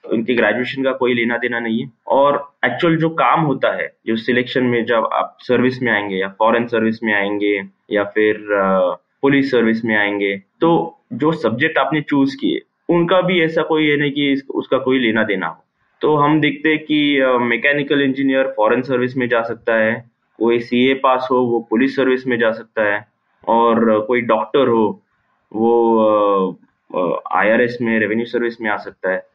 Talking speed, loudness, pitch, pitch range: 190 wpm, -17 LUFS, 120 Hz, 110-135 Hz